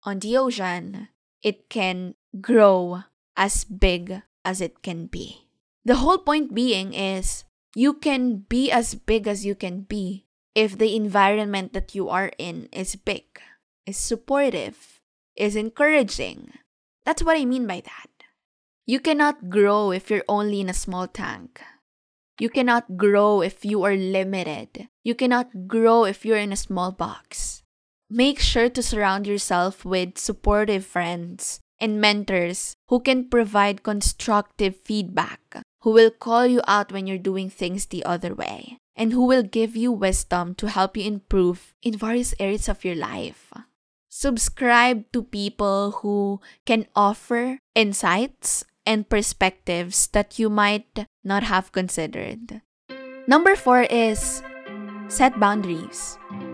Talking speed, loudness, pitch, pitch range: 140 wpm, -22 LUFS, 210 Hz, 190-235 Hz